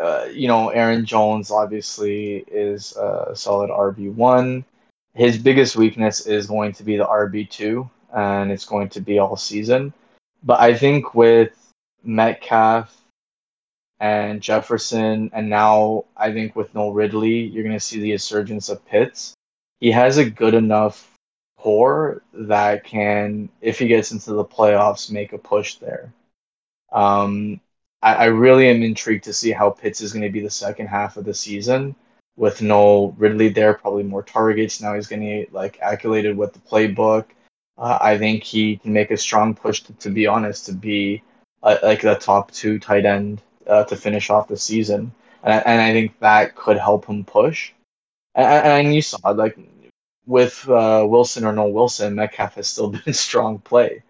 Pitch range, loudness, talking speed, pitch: 105-115 Hz, -18 LUFS, 175 wpm, 105 Hz